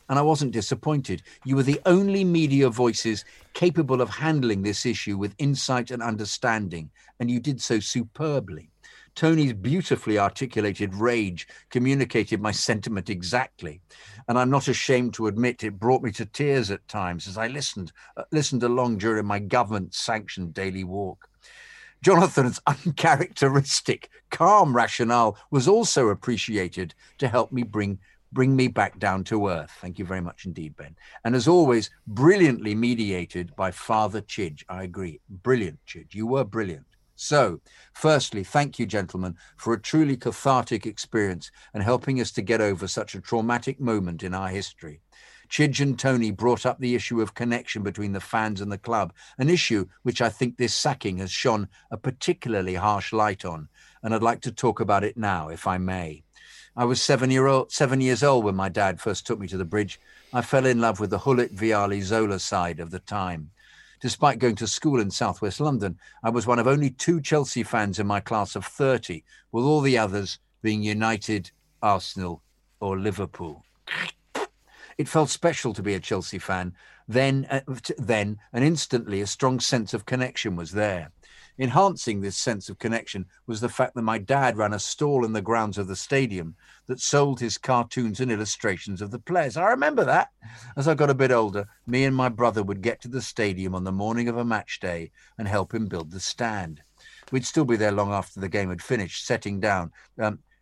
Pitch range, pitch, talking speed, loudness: 100-130 Hz, 115 Hz, 185 wpm, -25 LUFS